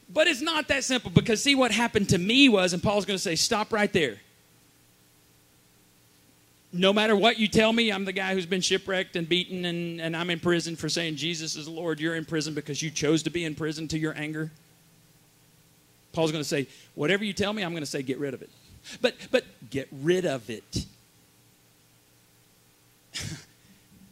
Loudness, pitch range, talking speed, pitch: -26 LUFS, 135-195 Hz, 190 wpm, 165 Hz